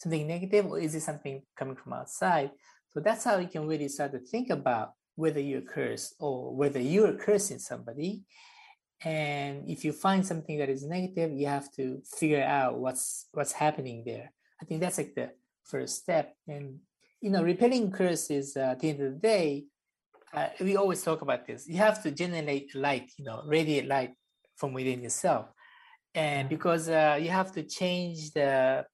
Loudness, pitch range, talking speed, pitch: -30 LUFS, 140-180 Hz, 185 wpm, 155 Hz